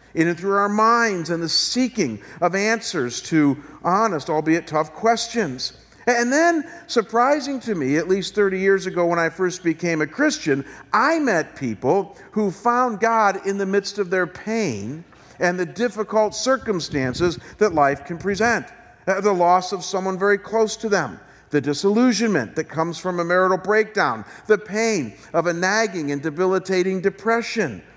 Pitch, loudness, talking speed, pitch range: 190 Hz, -21 LUFS, 160 wpm, 165-220 Hz